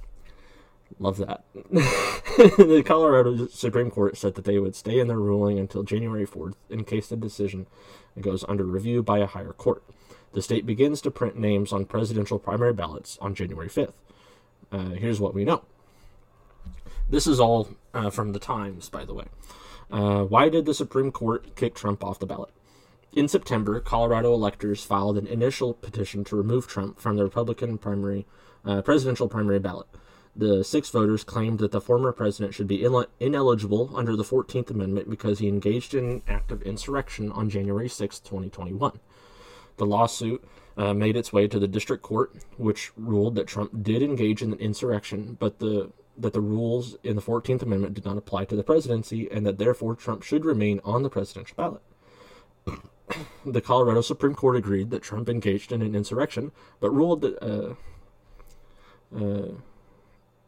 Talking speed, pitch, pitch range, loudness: 170 wpm, 100 Hz, 100-120 Hz, -25 LUFS